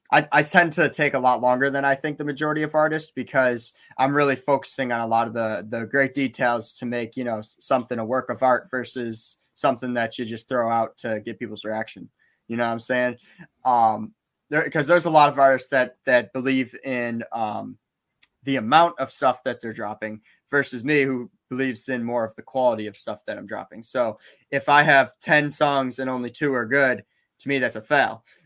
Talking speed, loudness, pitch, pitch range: 215 wpm, -22 LUFS, 130 Hz, 115-140 Hz